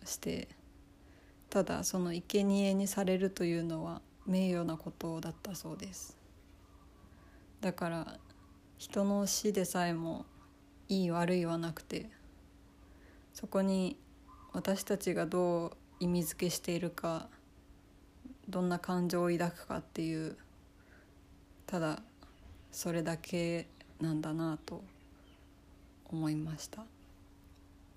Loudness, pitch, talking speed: -36 LUFS, 165 Hz, 205 characters per minute